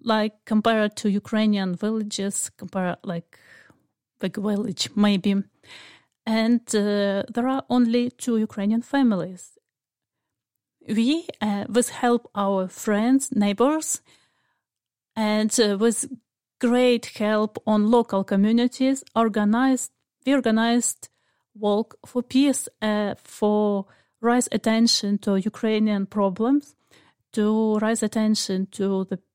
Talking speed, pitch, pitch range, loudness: 105 wpm, 215 Hz, 205-240 Hz, -23 LUFS